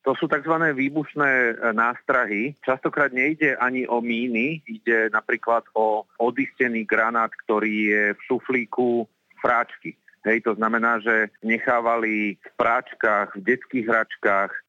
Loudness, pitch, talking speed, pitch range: -22 LUFS, 115 Hz, 120 wpm, 110-130 Hz